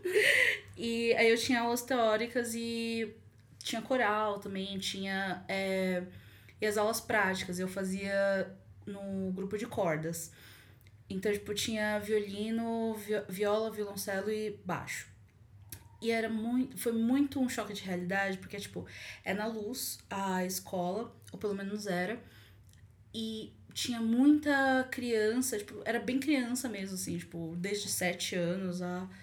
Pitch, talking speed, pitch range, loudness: 200 Hz, 135 wpm, 180-230 Hz, -33 LUFS